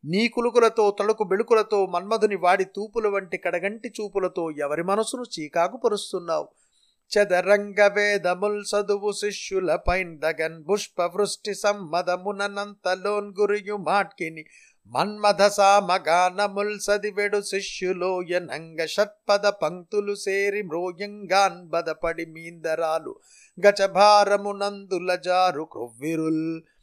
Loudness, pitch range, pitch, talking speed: -24 LUFS, 180-205 Hz, 200 Hz, 70 wpm